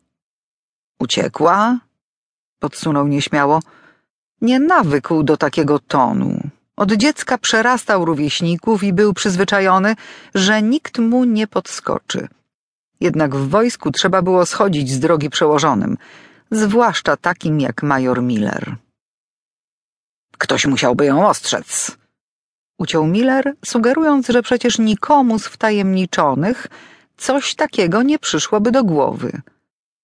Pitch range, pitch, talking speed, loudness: 160-240 Hz, 205 Hz, 105 wpm, -16 LUFS